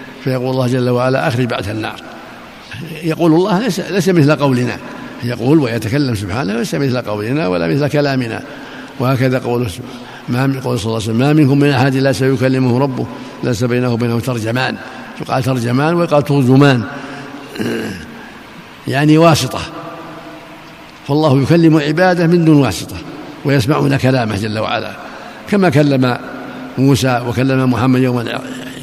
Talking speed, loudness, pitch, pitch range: 125 wpm, -14 LUFS, 135 Hz, 125-150 Hz